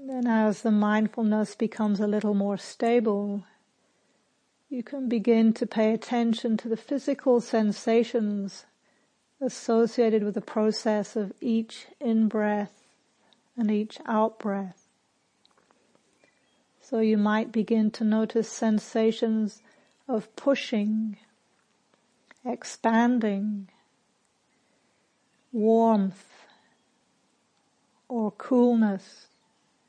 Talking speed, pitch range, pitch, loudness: 85 wpm, 215-240 Hz, 225 Hz, -26 LUFS